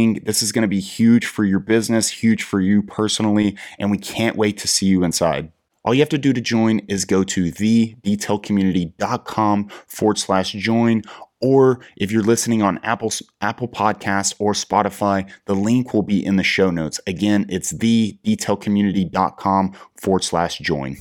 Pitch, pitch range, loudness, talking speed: 105 Hz, 95-115 Hz, -19 LUFS, 150 wpm